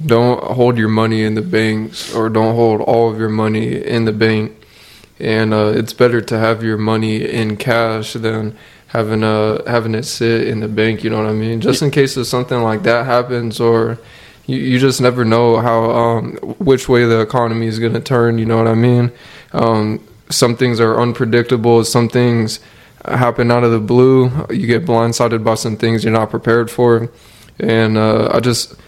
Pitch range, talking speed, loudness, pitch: 110-120 Hz, 200 wpm, -14 LUFS, 115 Hz